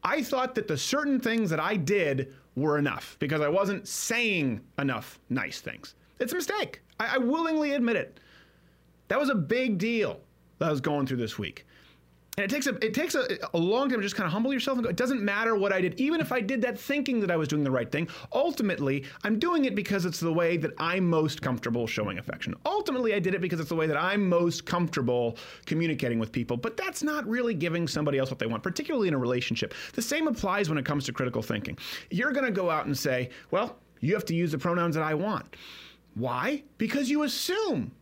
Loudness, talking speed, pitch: -28 LUFS, 235 wpm, 185 Hz